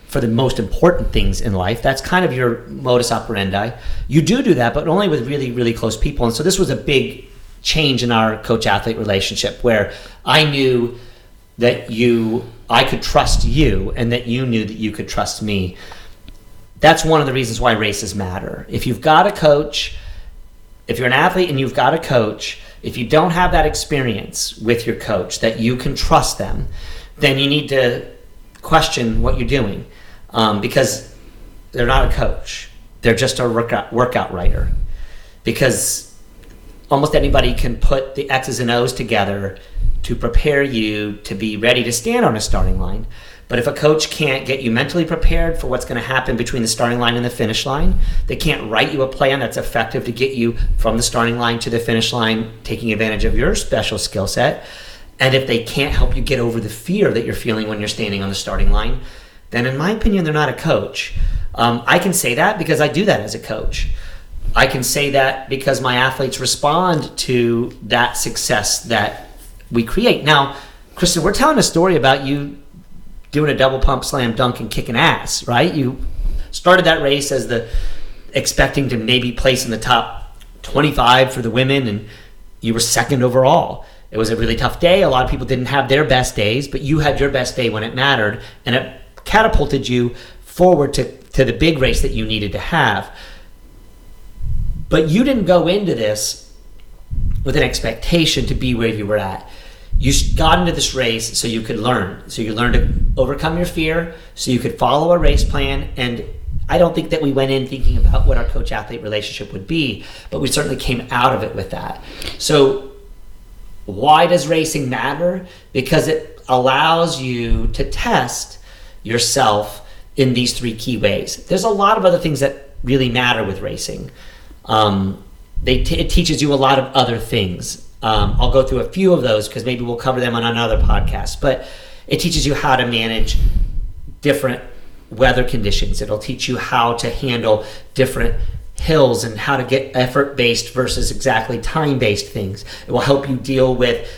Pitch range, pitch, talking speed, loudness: 110-140 Hz, 125 Hz, 195 wpm, -17 LUFS